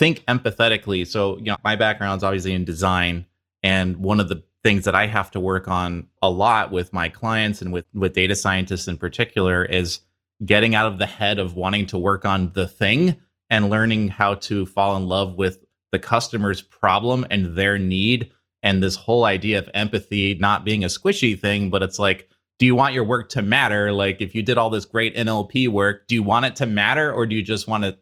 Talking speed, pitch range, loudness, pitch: 220 wpm, 95-110 Hz, -20 LUFS, 100 Hz